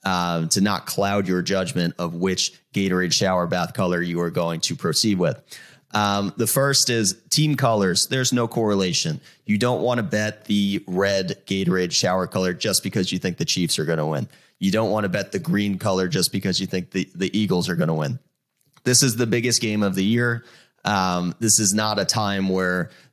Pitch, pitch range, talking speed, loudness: 100 Hz, 90-110 Hz, 210 wpm, -21 LUFS